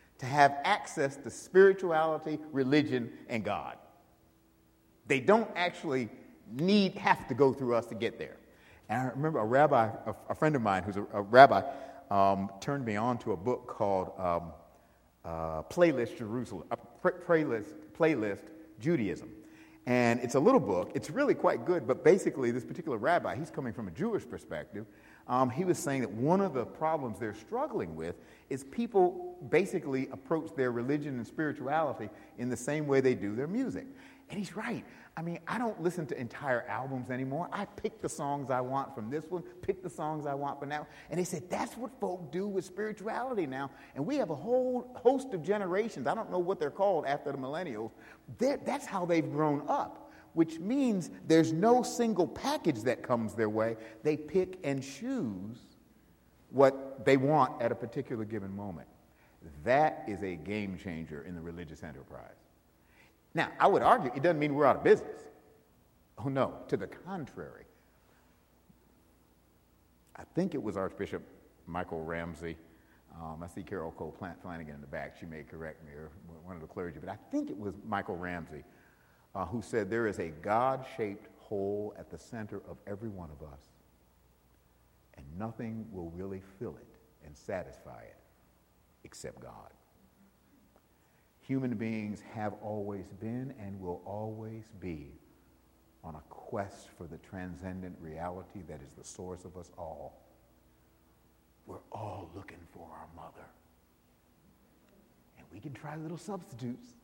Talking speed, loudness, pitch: 170 wpm, -32 LUFS, 115 Hz